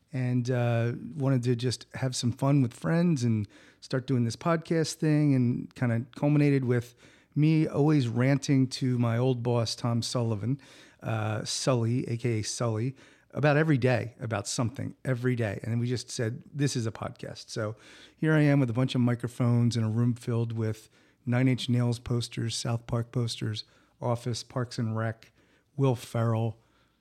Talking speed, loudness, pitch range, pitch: 170 wpm, -28 LUFS, 115-135 Hz, 125 Hz